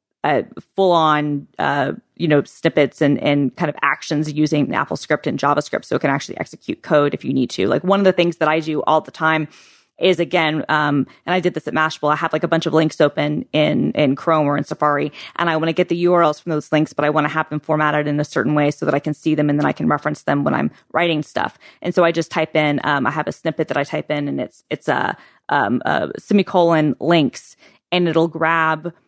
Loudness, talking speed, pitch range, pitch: -18 LUFS, 255 wpm, 150-165 Hz, 155 Hz